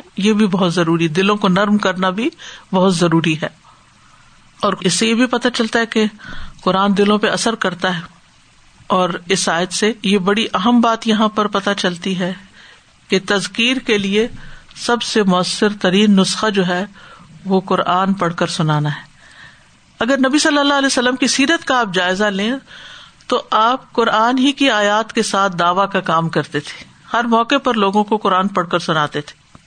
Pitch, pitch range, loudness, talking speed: 200 Hz, 185-225 Hz, -16 LUFS, 185 wpm